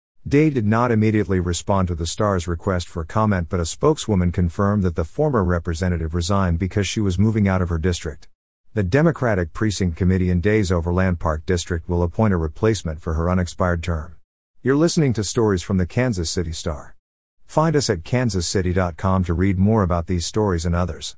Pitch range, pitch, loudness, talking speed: 85-105 Hz, 95 Hz, -21 LUFS, 185 wpm